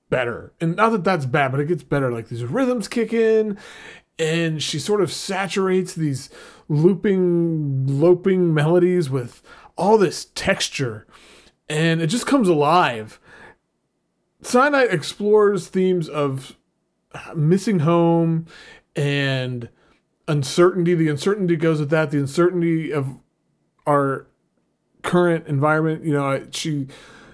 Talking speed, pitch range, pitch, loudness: 120 wpm, 145-185 Hz, 165 Hz, -20 LUFS